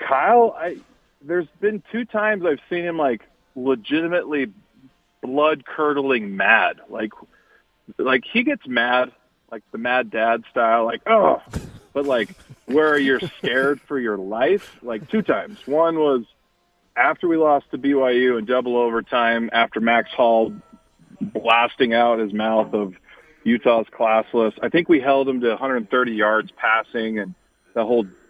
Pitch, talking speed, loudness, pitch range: 125 Hz, 150 wpm, -20 LUFS, 115-155 Hz